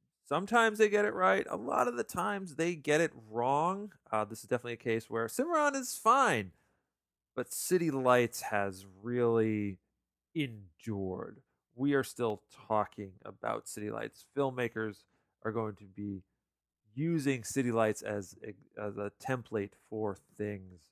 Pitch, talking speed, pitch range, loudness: 115 Hz, 150 wpm, 105-145 Hz, -33 LUFS